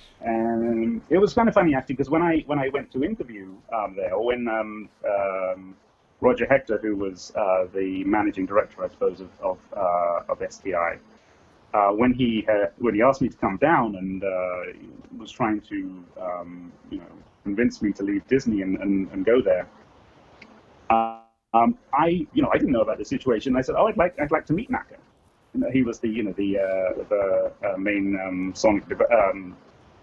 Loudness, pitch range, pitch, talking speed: -24 LUFS, 95-130 Hz, 105 Hz, 200 wpm